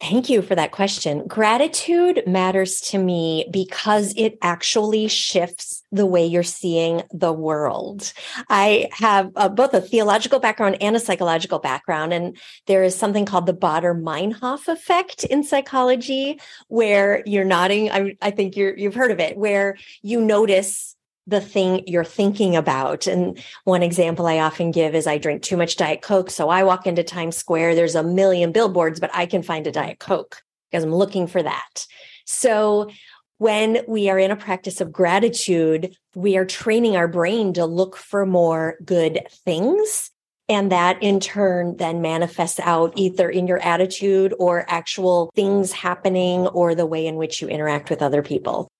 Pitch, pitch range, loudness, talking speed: 190 Hz, 170-210 Hz, -20 LUFS, 170 wpm